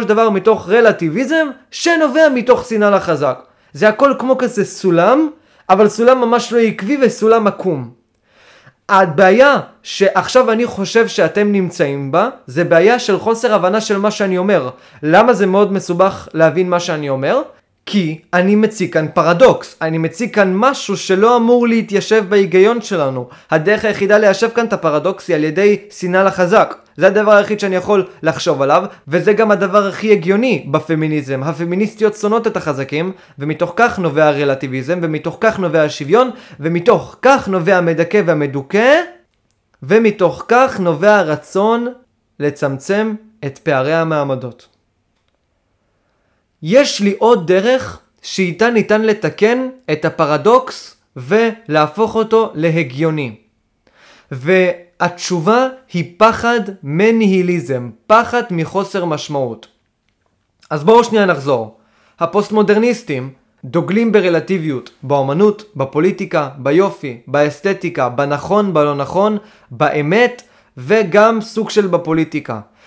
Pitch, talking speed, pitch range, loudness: 190 Hz, 120 wpm, 155-220 Hz, -14 LUFS